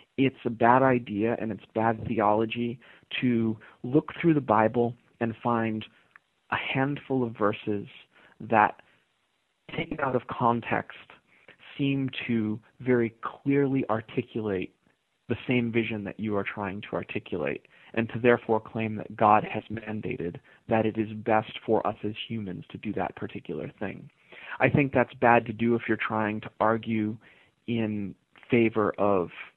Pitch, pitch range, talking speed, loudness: 115 Hz, 110-125 Hz, 150 wpm, -28 LUFS